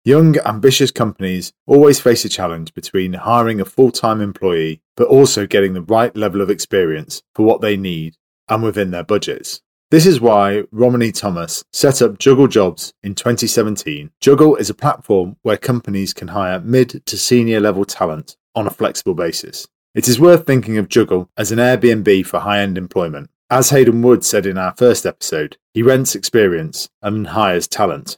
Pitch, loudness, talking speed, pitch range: 110 Hz, -14 LUFS, 175 wpm, 100-125 Hz